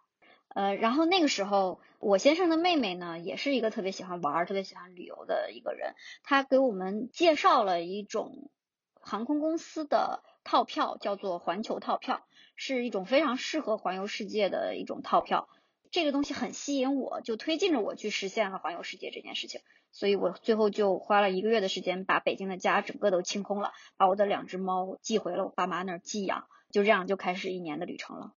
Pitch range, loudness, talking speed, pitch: 190-270 Hz, -30 LUFS, 315 characters per minute, 205 Hz